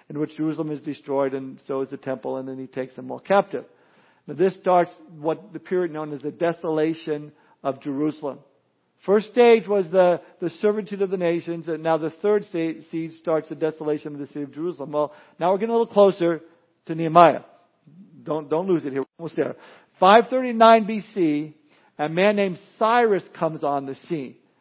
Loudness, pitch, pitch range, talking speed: -22 LUFS, 165 Hz, 150-190 Hz, 190 wpm